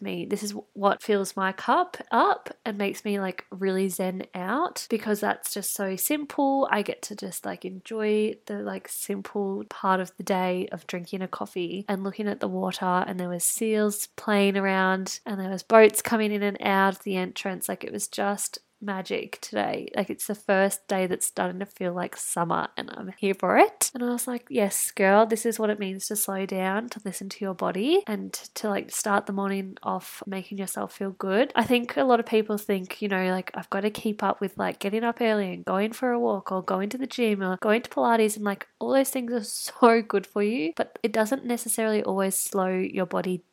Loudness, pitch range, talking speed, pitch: -26 LUFS, 190-225 Hz, 225 wpm, 200 Hz